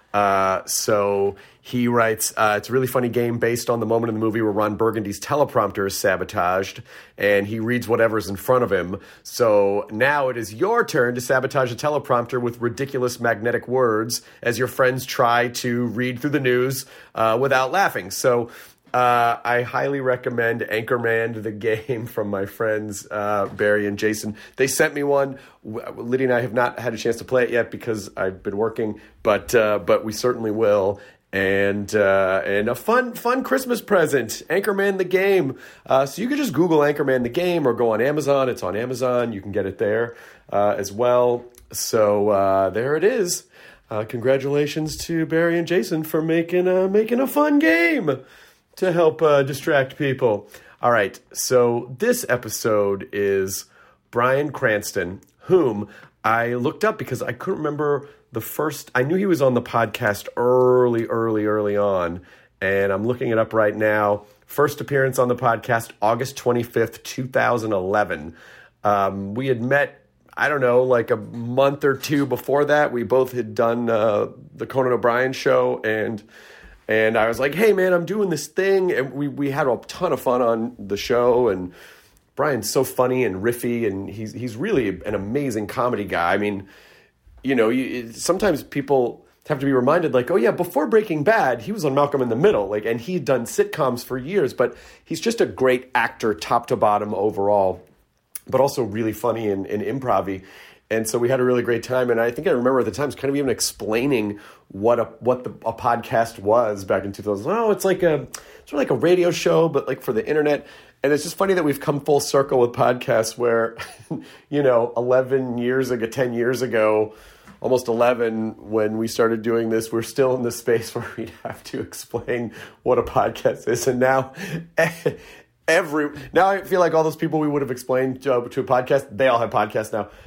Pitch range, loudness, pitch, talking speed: 110-140 Hz, -21 LUFS, 125 Hz, 190 wpm